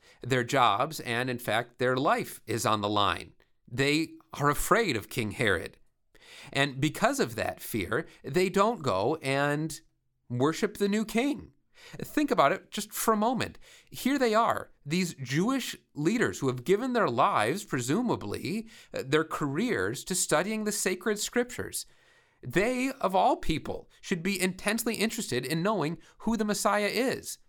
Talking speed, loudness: 155 wpm, -29 LUFS